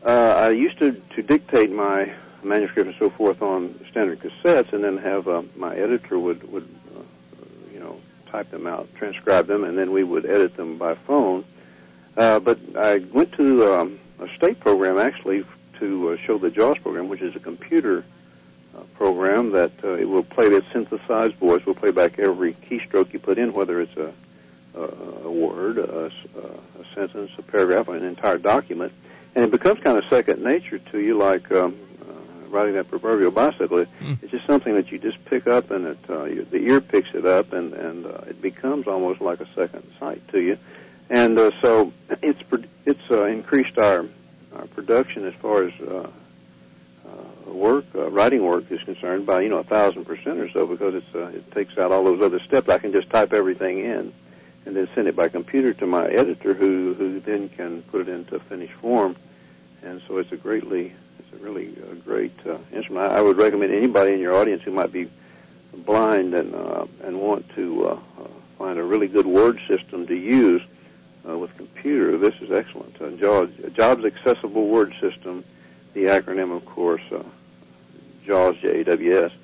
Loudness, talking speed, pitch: -21 LUFS, 195 wpm, 100 Hz